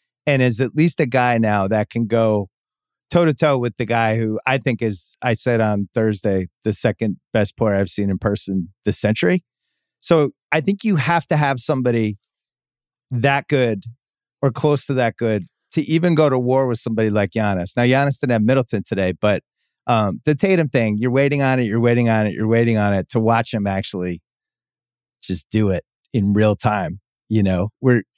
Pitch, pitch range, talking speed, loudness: 115 Hz, 105-135 Hz, 200 wpm, -19 LUFS